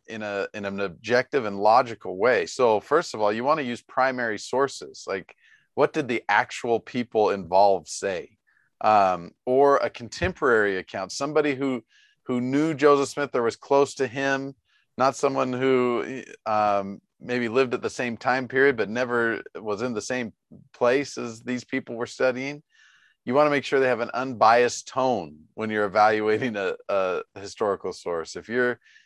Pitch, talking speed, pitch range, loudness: 125 Hz, 175 wpm, 115-140 Hz, -24 LUFS